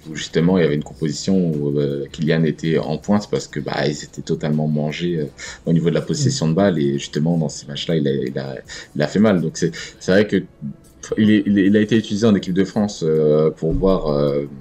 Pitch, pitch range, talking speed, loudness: 80 Hz, 75-95 Hz, 250 wpm, -19 LUFS